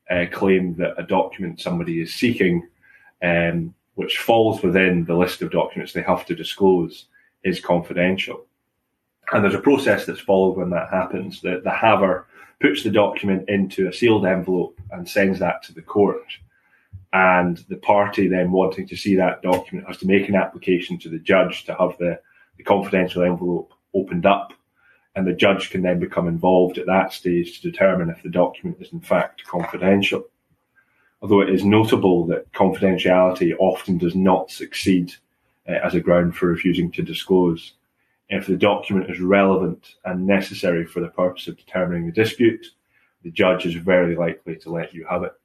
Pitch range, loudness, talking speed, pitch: 85-95 Hz, -20 LUFS, 175 wpm, 90 Hz